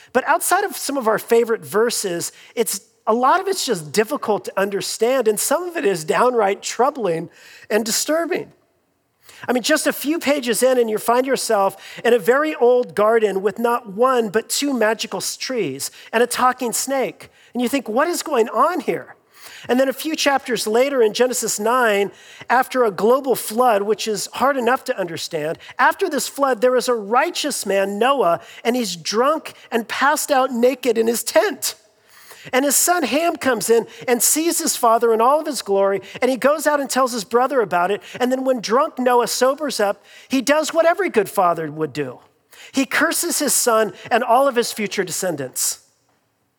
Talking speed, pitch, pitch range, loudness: 190 wpm, 245 Hz, 215-275 Hz, -19 LUFS